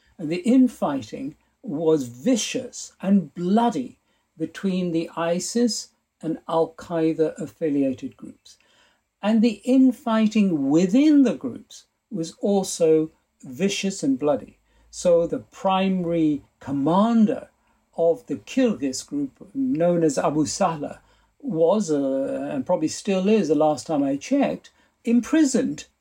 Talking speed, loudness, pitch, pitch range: 115 wpm, -22 LUFS, 200 Hz, 165-255 Hz